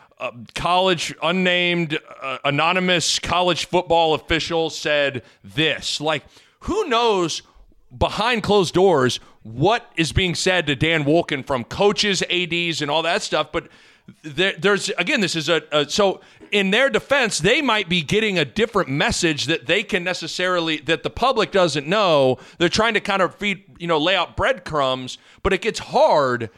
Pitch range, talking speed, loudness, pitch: 150-195 Hz, 165 wpm, -19 LUFS, 170 Hz